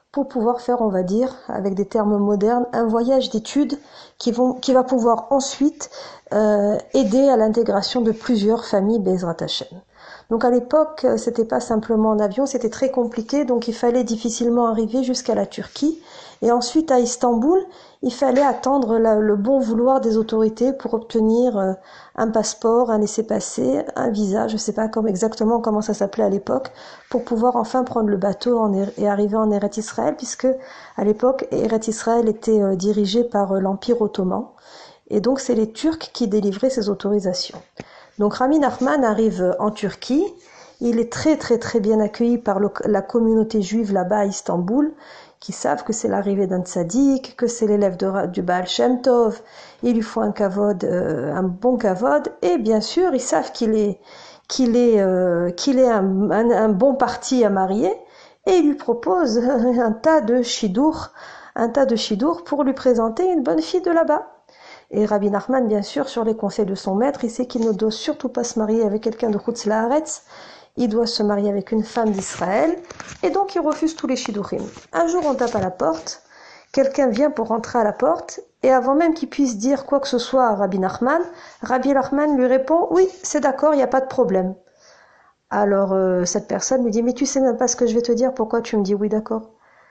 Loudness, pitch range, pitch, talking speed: -20 LUFS, 210-260 Hz, 235 Hz, 195 wpm